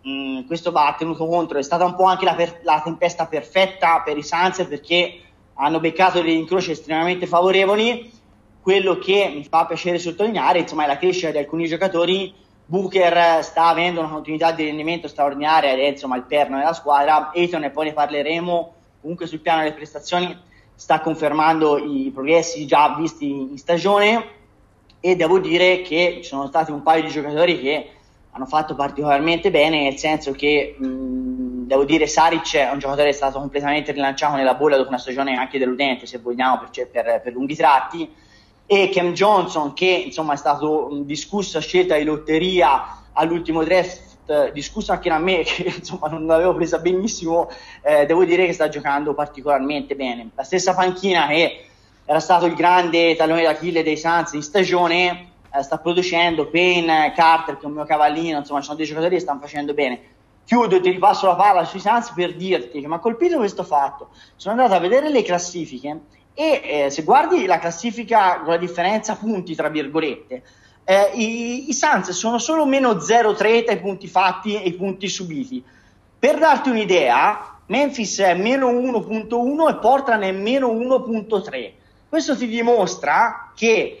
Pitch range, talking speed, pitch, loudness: 145-185 Hz, 175 wpm, 165 Hz, -19 LUFS